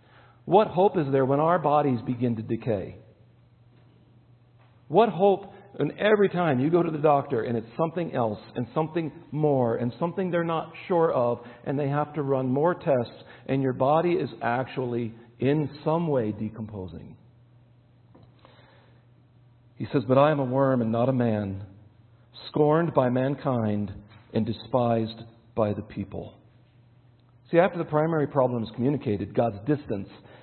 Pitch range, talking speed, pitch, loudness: 115-150 Hz, 150 wpm, 125 Hz, -26 LUFS